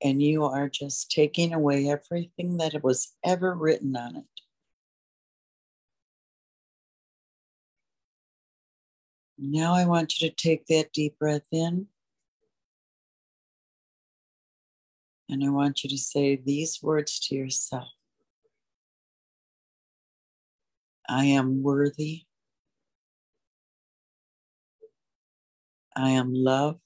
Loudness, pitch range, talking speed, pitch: -26 LUFS, 140-160 Hz, 85 wpm, 150 Hz